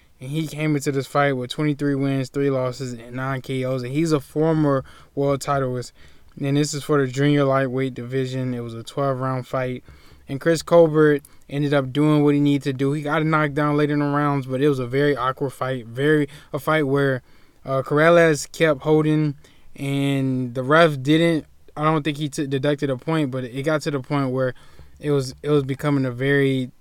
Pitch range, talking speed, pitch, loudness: 130-150 Hz, 210 wpm, 140 Hz, -21 LUFS